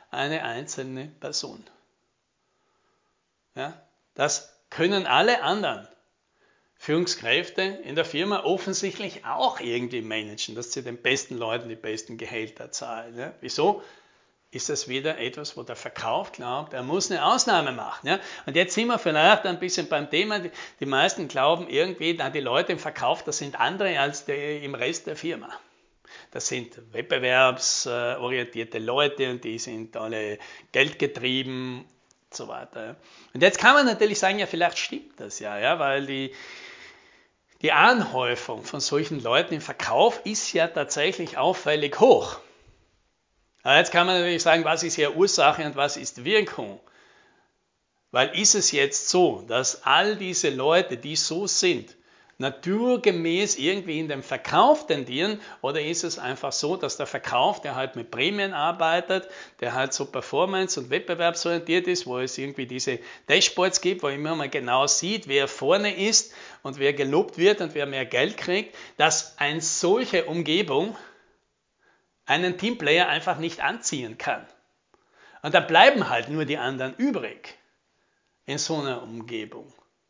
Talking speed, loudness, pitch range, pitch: 150 wpm, -24 LUFS, 135-195 Hz, 165 Hz